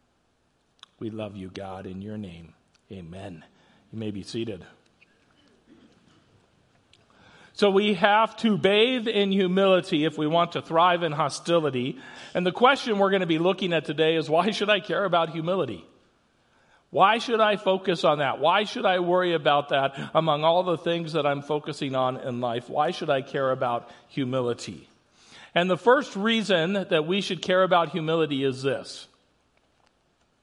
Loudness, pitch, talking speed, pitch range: -24 LUFS, 165 Hz, 165 wpm, 135-195 Hz